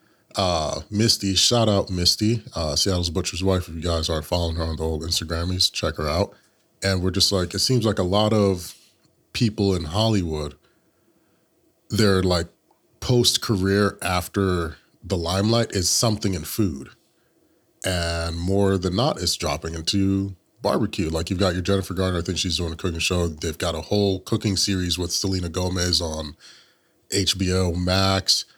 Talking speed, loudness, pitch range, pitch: 165 wpm, -22 LUFS, 85-100 Hz, 95 Hz